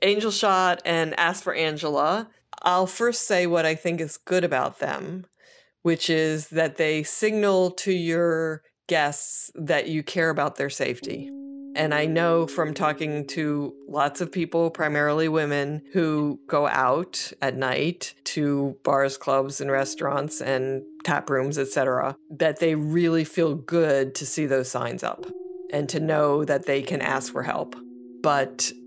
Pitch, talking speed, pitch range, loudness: 155 Hz, 155 wpm, 140-170 Hz, -24 LUFS